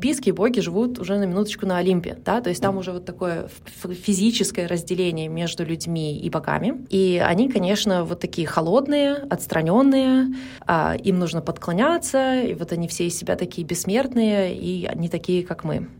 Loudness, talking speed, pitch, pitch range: -22 LUFS, 175 wpm, 185 Hz, 175-225 Hz